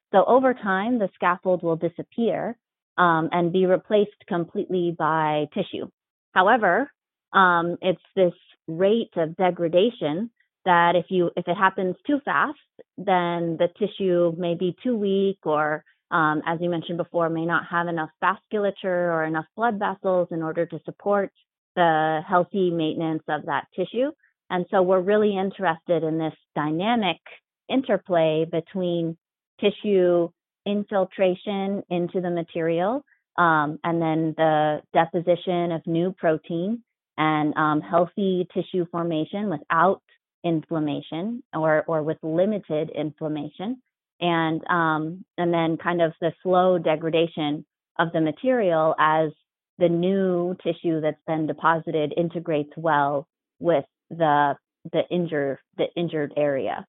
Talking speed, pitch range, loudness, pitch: 130 wpm, 160-190 Hz, -24 LUFS, 170 Hz